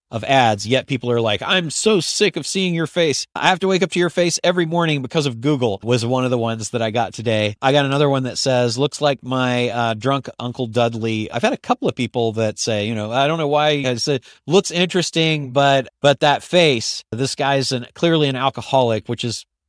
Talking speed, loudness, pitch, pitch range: 240 wpm, -18 LUFS, 135 Hz, 120-150 Hz